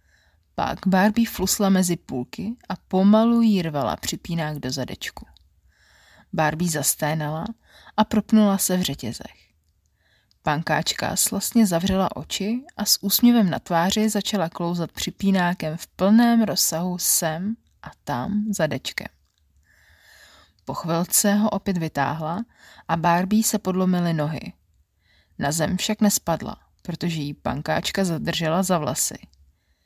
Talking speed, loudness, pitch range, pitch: 115 wpm, -22 LUFS, 140-200 Hz, 170 Hz